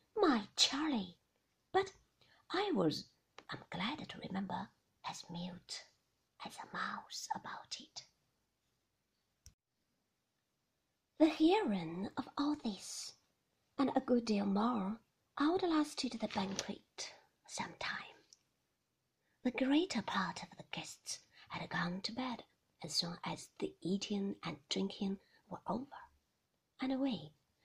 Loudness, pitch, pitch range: -39 LUFS, 230 Hz, 190-285 Hz